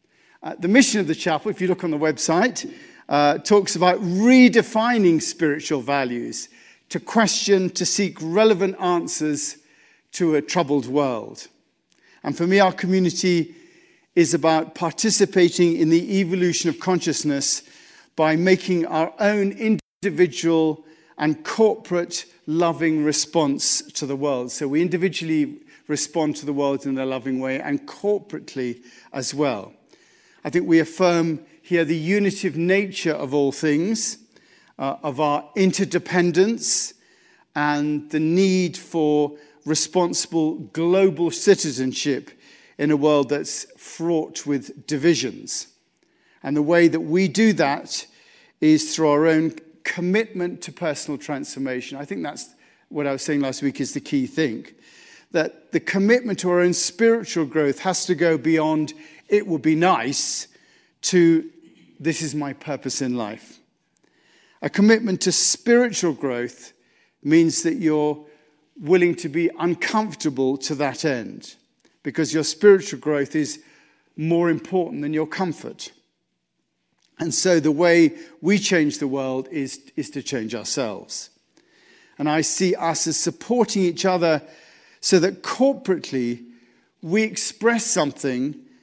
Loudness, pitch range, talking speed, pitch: -21 LUFS, 150-185 Hz, 135 wpm, 165 Hz